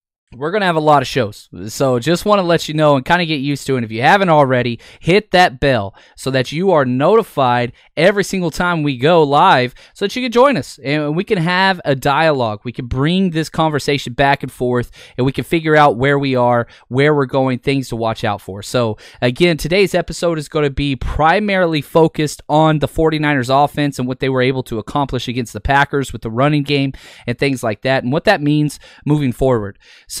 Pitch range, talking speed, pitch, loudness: 125-160 Hz, 225 wpm, 140 Hz, -15 LUFS